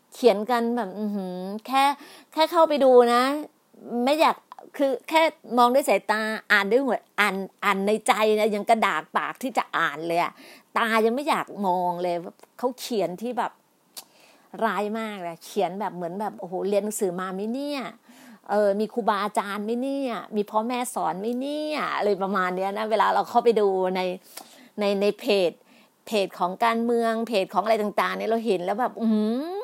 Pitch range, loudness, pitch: 200-245 Hz, -24 LUFS, 220 Hz